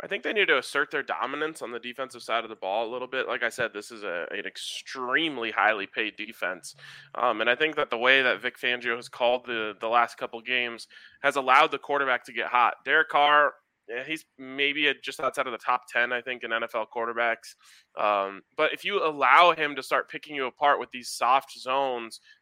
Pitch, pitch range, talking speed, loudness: 125 Hz, 115-135 Hz, 225 wpm, -26 LUFS